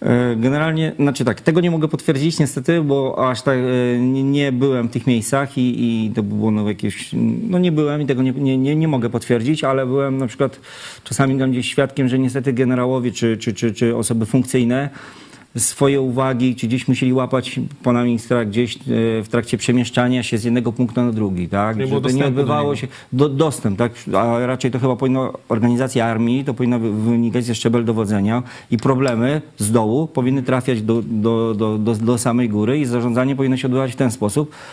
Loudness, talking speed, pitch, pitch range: -18 LUFS, 190 wpm, 125 Hz, 120-135 Hz